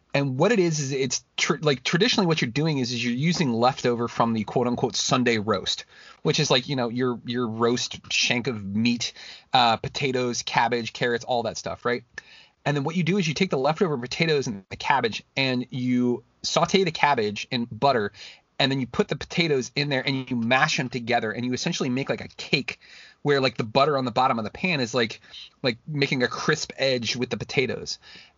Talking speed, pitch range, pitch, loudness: 220 wpm, 120-145 Hz, 130 Hz, -24 LUFS